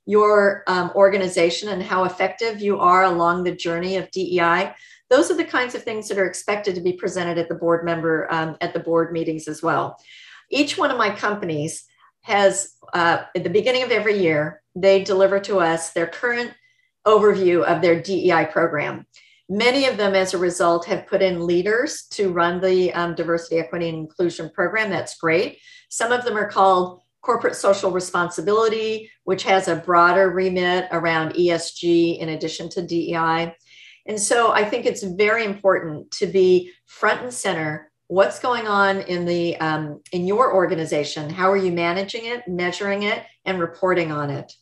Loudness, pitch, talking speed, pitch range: -20 LUFS, 185 Hz, 180 wpm, 170-205 Hz